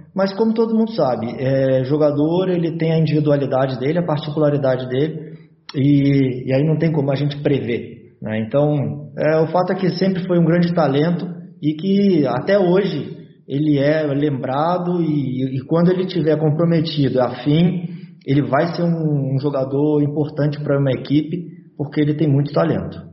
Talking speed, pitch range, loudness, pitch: 170 wpm, 140-170 Hz, -18 LUFS, 150 Hz